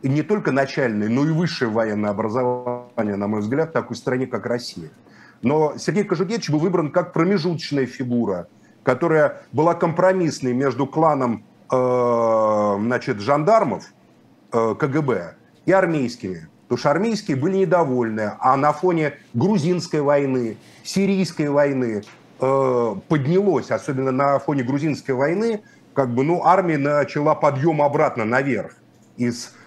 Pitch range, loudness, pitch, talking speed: 120-165 Hz, -20 LUFS, 140 Hz, 125 wpm